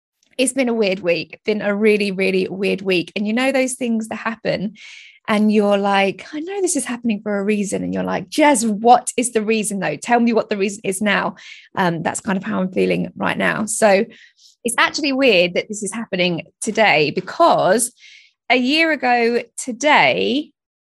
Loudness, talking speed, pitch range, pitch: -18 LUFS, 195 wpm, 195-255 Hz, 220 Hz